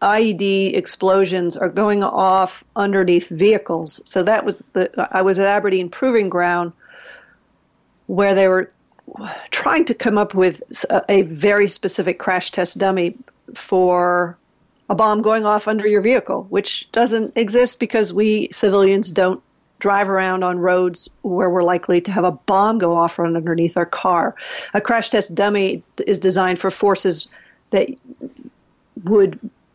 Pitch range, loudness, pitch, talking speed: 180-210 Hz, -17 LUFS, 195 Hz, 150 wpm